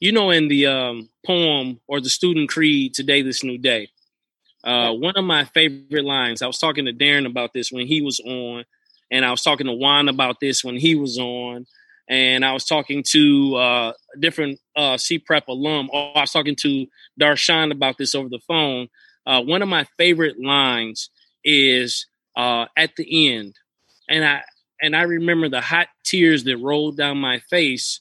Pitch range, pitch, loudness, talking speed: 125-155 Hz, 140 Hz, -18 LUFS, 195 wpm